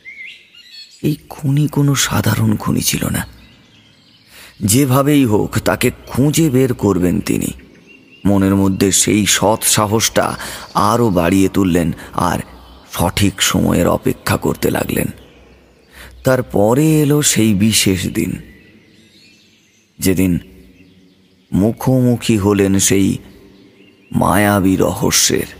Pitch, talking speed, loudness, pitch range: 105 Hz, 95 wpm, -15 LUFS, 95-125 Hz